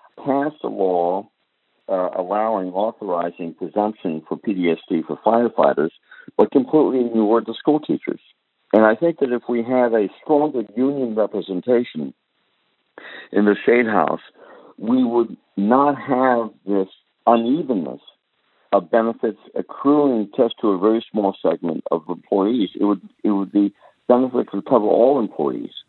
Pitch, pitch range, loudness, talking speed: 115 Hz, 100-125 Hz, -20 LUFS, 140 wpm